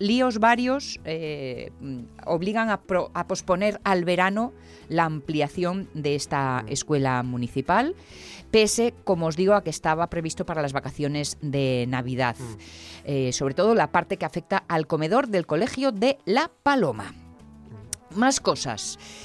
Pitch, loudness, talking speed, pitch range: 160 Hz, -25 LUFS, 140 wpm, 135-200 Hz